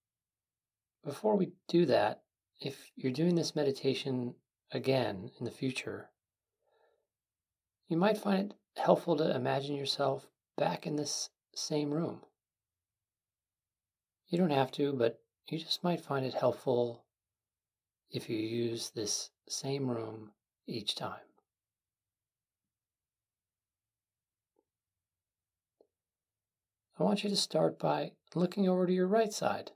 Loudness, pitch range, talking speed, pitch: -33 LUFS, 100-150 Hz, 115 wpm, 120 Hz